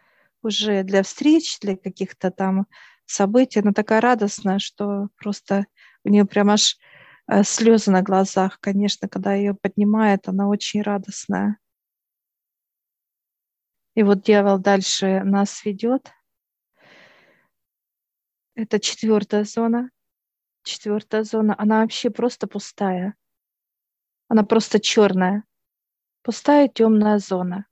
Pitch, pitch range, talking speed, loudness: 205 Hz, 200-220 Hz, 100 wpm, -20 LUFS